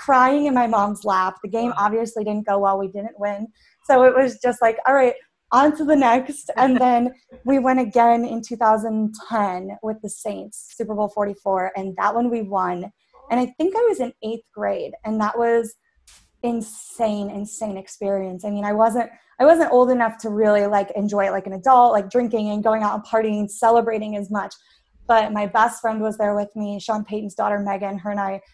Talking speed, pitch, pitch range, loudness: 210 wpm, 220 Hz, 205-240 Hz, -20 LUFS